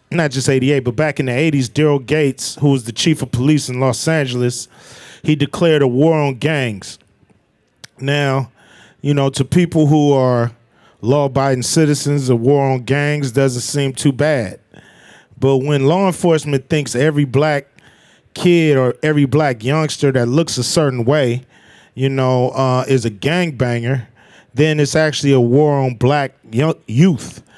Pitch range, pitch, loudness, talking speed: 130-150 Hz, 140 Hz, -15 LUFS, 160 wpm